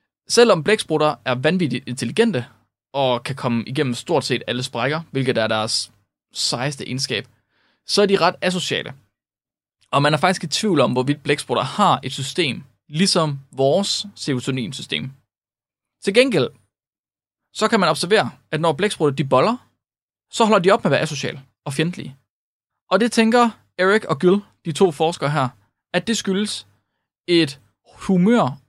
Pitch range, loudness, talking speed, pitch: 125-185 Hz, -20 LUFS, 155 wpm, 150 Hz